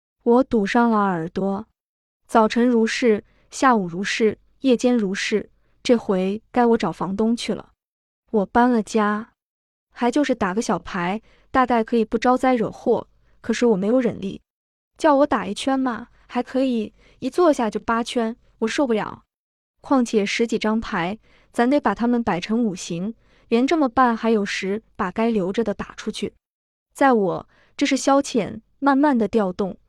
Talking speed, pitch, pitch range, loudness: 230 characters per minute, 230 Hz, 210-245 Hz, -21 LUFS